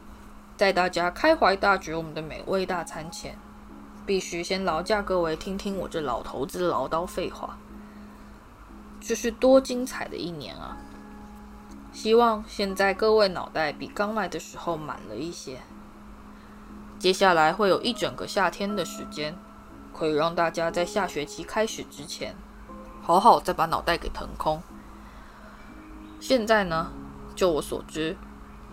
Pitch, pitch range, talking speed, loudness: 180 Hz, 155-210 Hz, 215 characters per minute, -26 LUFS